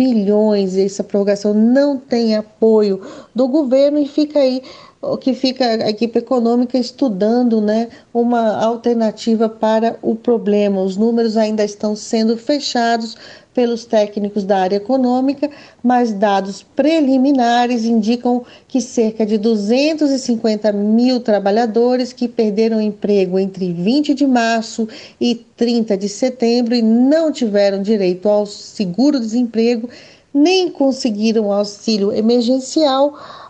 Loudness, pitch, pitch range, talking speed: -16 LUFS, 230 Hz, 215-255 Hz, 120 wpm